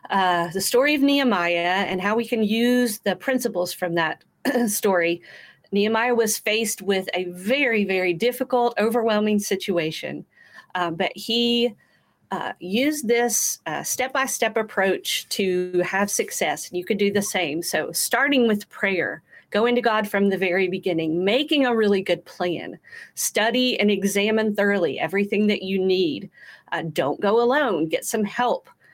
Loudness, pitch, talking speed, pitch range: -22 LUFS, 210 Hz, 155 wpm, 185-240 Hz